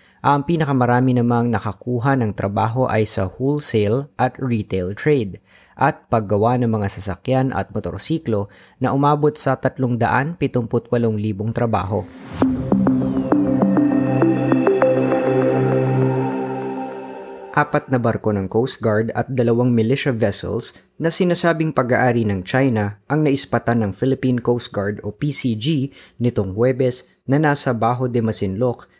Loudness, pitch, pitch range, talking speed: -19 LUFS, 120 Hz, 100-130 Hz, 110 wpm